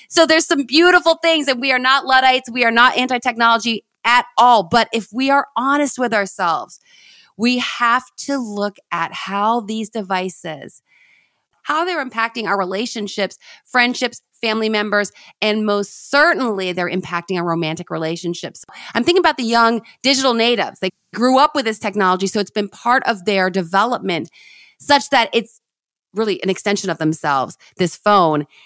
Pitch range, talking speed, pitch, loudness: 195-255 Hz, 160 wpm, 225 Hz, -17 LUFS